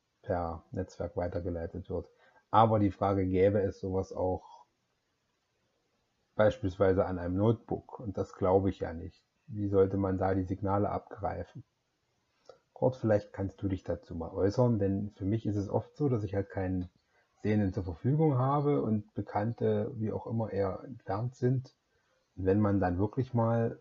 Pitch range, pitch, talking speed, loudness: 95-115 Hz, 100 Hz, 165 wpm, -32 LUFS